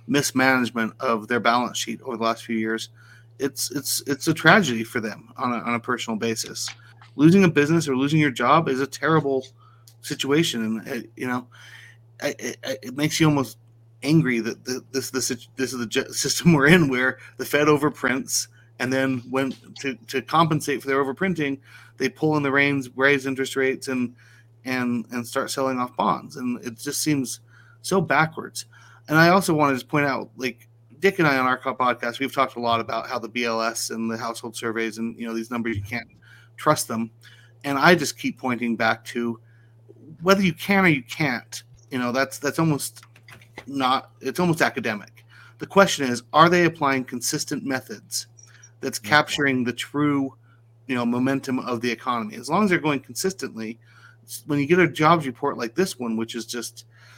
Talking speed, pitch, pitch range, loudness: 190 wpm, 125 Hz, 115-140 Hz, -23 LUFS